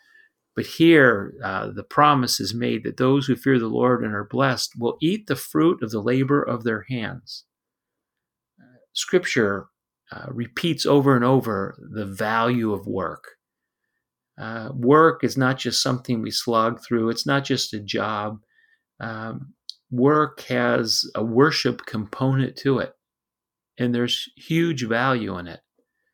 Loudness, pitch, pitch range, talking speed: -22 LUFS, 120 Hz, 110-135 Hz, 150 wpm